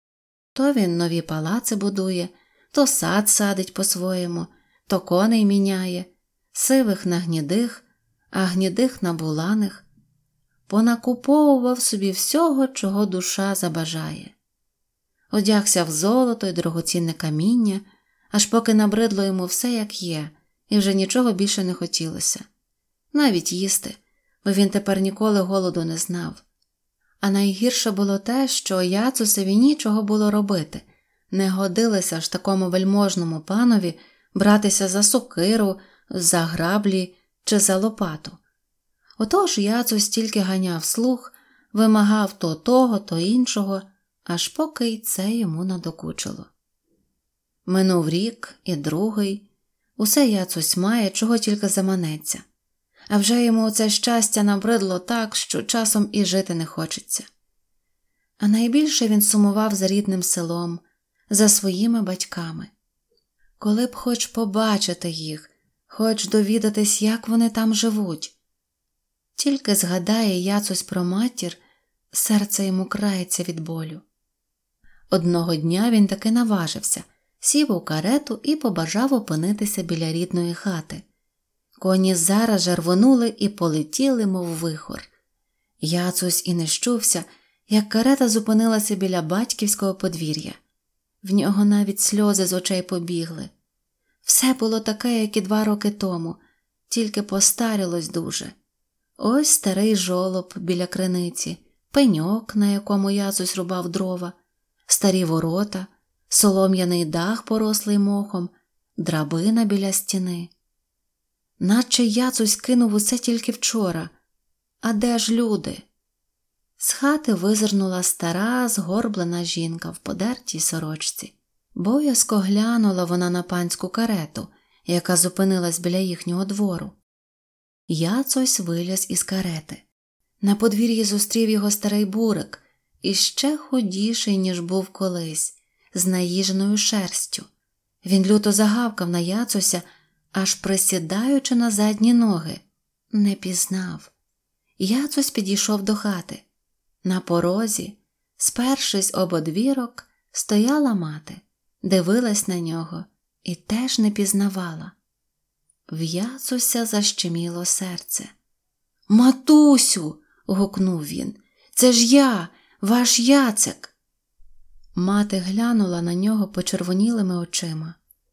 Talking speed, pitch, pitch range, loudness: 110 wpm, 200 Hz, 180-225 Hz, -21 LUFS